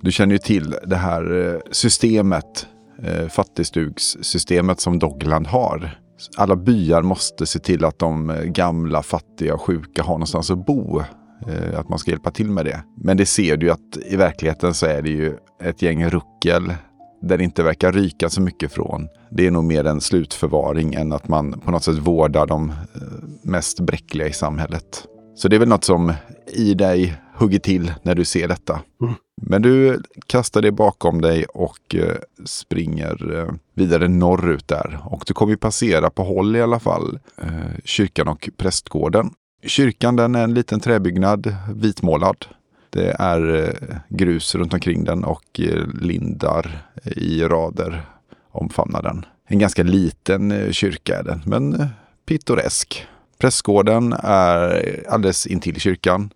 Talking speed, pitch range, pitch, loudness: 155 wpm, 80-100 Hz, 90 Hz, -19 LUFS